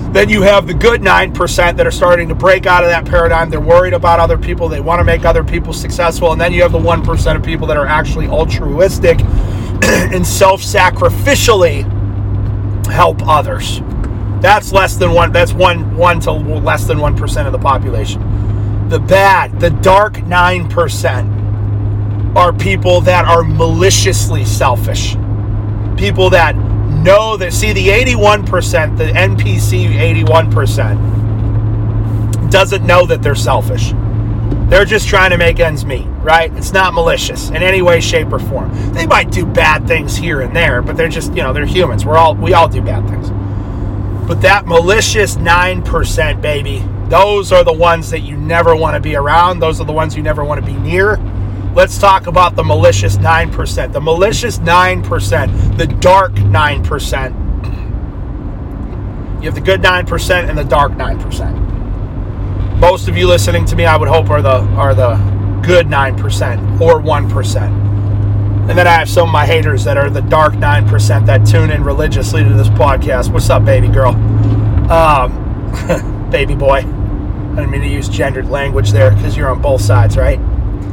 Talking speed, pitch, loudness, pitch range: 175 wpm, 105 Hz, -11 LUFS, 100-110 Hz